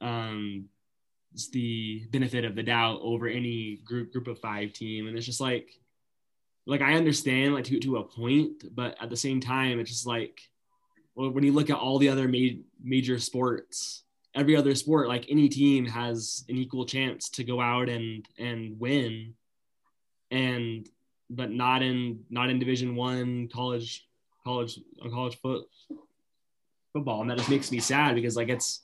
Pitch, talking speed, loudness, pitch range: 125 Hz, 175 wpm, -28 LUFS, 115-130 Hz